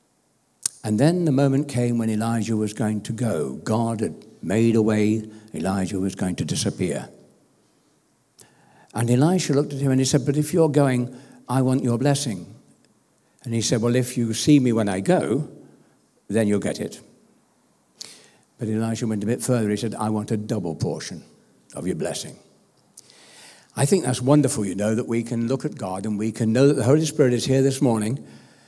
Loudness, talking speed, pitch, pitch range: -22 LUFS, 195 wpm, 120 Hz, 110-135 Hz